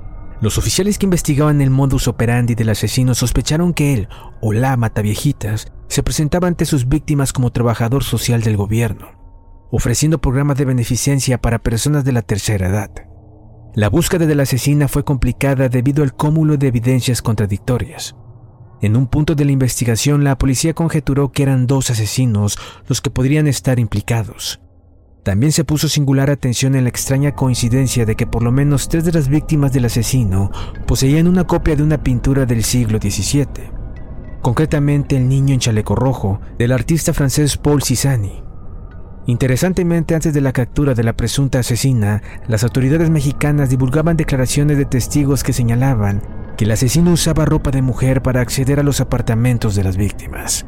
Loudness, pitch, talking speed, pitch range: -16 LUFS, 130 Hz, 165 wpm, 115-145 Hz